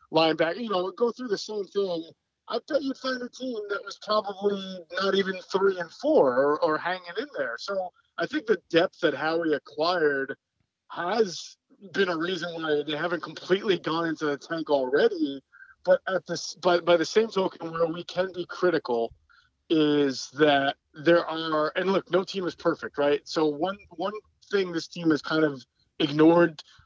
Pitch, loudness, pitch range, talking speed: 175 Hz, -26 LUFS, 160-195 Hz, 185 wpm